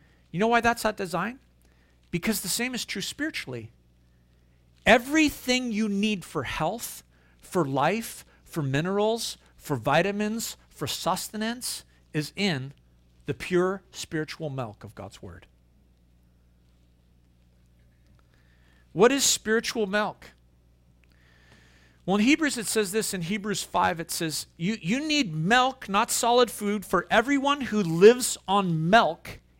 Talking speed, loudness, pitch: 125 wpm, -25 LUFS, 170 Hz